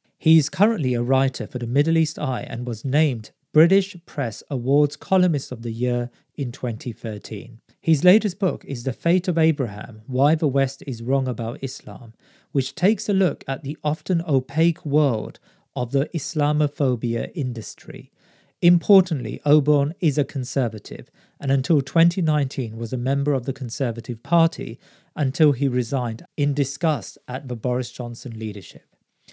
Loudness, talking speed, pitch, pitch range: -22 LUFS, 155 wpm, 140 Hz, 125-155 Hz